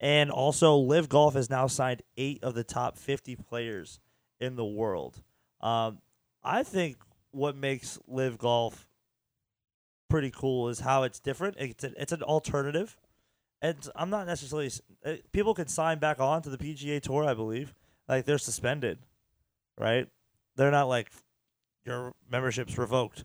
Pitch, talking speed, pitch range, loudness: 135 Hz, 150 wpm, 120-150 Hz, -30 LUFS